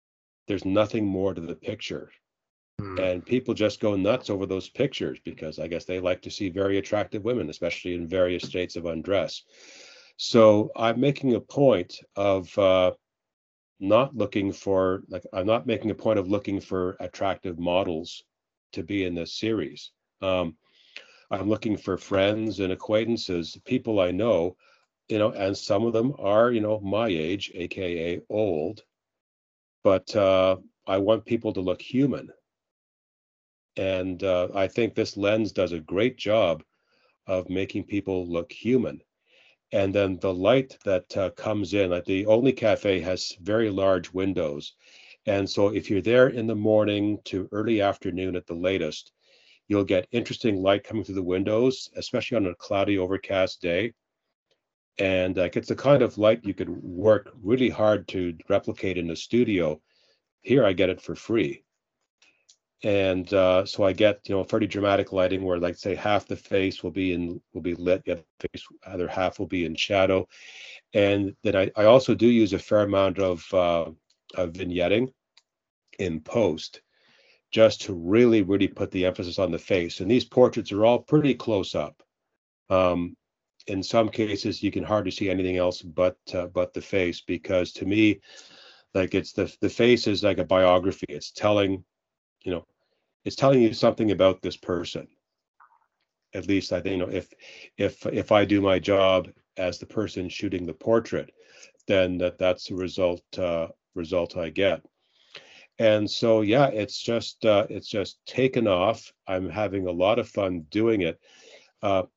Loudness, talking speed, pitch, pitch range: -25 LUFS, 170 wpm, 95 Hz, 90-110 Hz